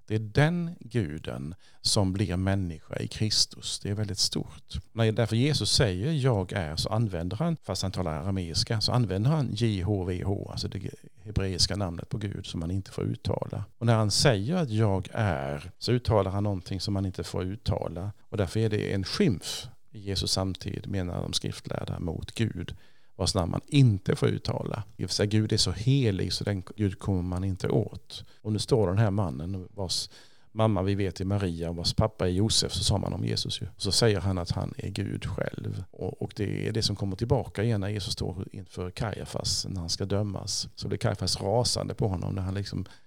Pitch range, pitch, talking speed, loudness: 95-115 Hz, 105 Hz, 200 wpm, -29 LUFS